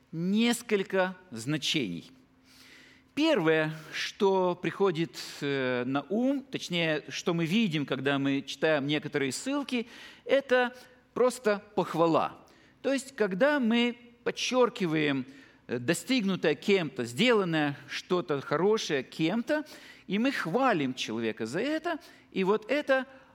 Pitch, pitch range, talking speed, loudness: 190 Hz, 150-245 Hz, 100 wpm, -29 LUFS